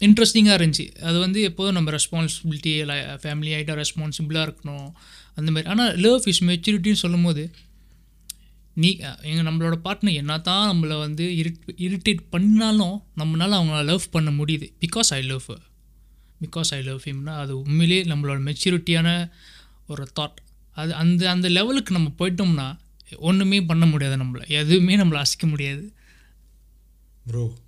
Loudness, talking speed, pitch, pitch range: -21 LUFS, 135 wpm, 165 Hz, 150-180 Hz